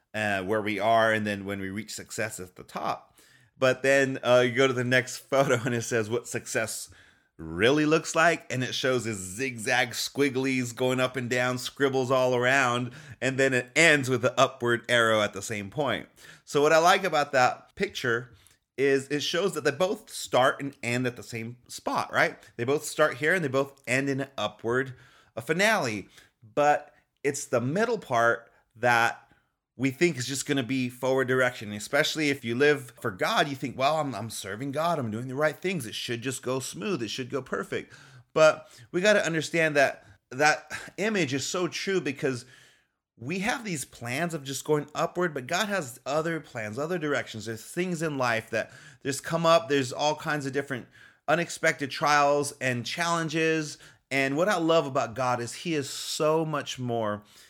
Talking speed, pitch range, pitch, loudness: 195 wpm, 120-155 Hz, 135 Hz, -27 LUFS